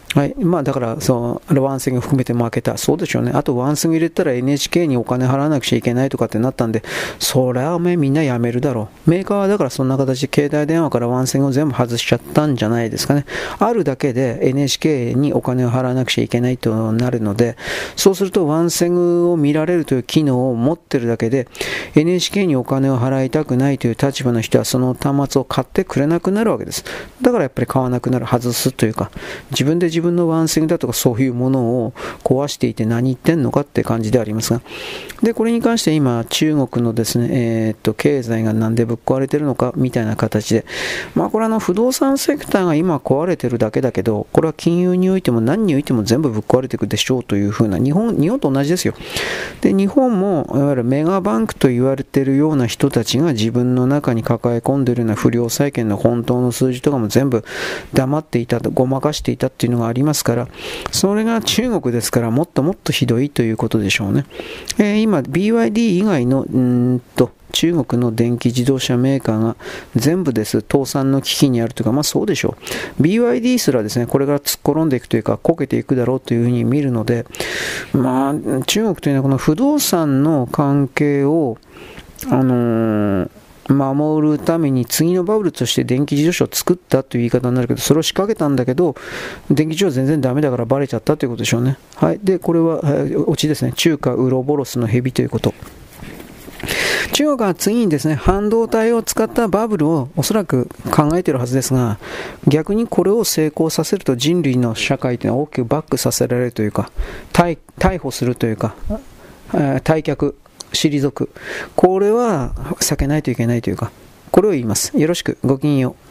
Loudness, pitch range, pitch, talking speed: -17 LUFS, 120-160 Hz, 135 Hz, 420 characters per minute